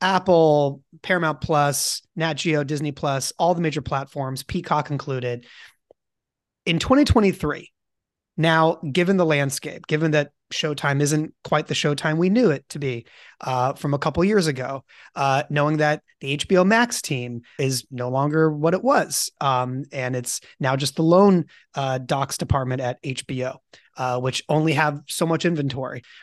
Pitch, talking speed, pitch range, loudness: 145 Hz, 160 wpm, 135-160 Hz, -22 LUFS